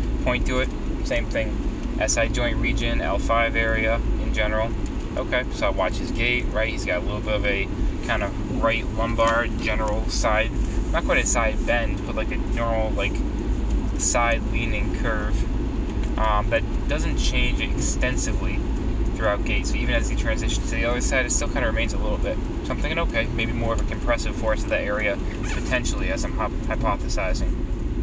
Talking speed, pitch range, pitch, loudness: 185 wpm, 105-115 Hz, 110 Hz, -24 LUFS